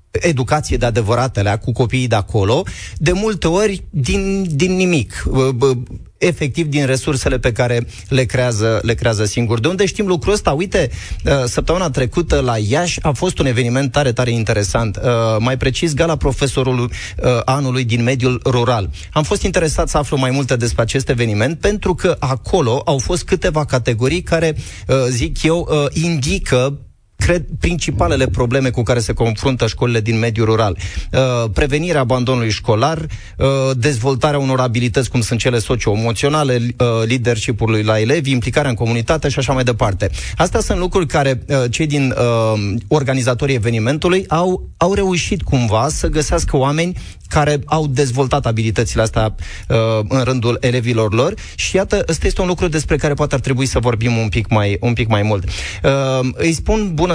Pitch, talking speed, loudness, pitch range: 130 Hz, 160 wpm, -16 LUFS, 115-150 Hz